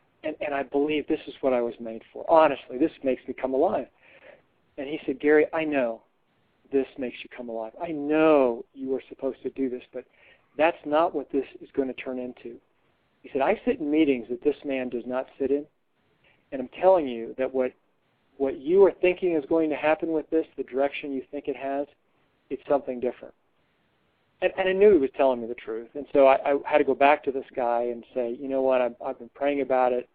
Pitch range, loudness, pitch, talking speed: 125-150 Hz, -26 LUFS, 135 Hz, 230 wpm